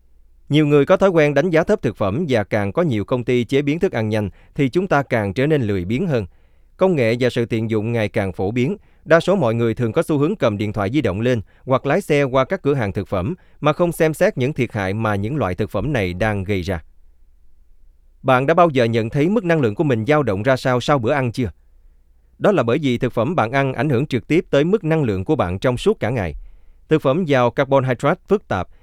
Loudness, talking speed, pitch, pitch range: -19 LUFS, 260 wpm, 125 Hz, 105-150 Hz